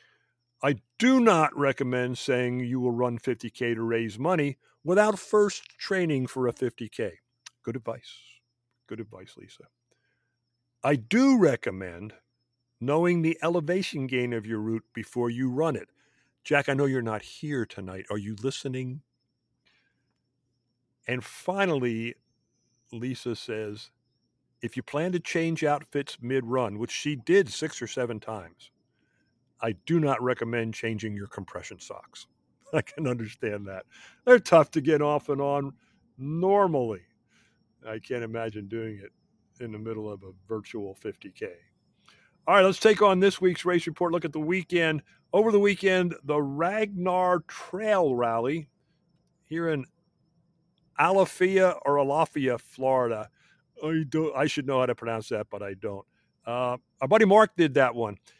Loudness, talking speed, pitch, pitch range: -26 LUFS, 145 wpm, 135 Hz, 120-165 Hz